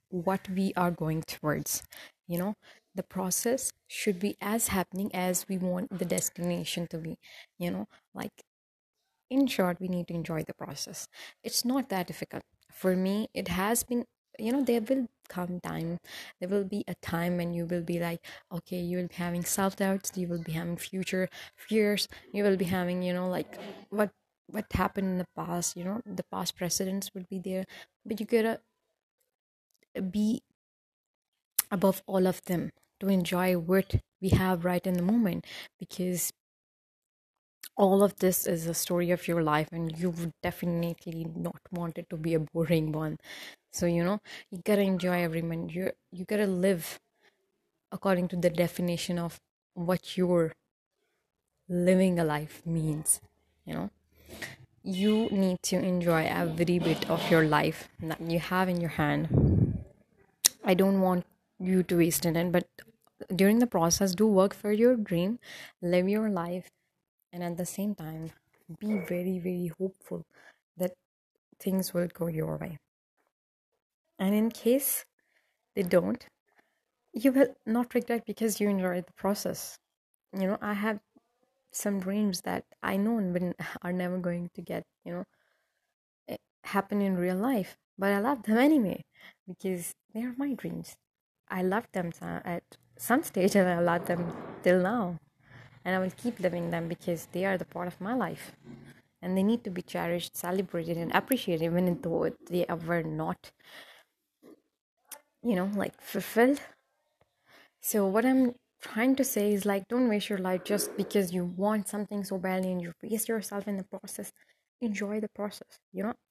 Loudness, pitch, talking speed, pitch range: -30 LUFS, 185 Hz, 165 wpm, 175-205 Hz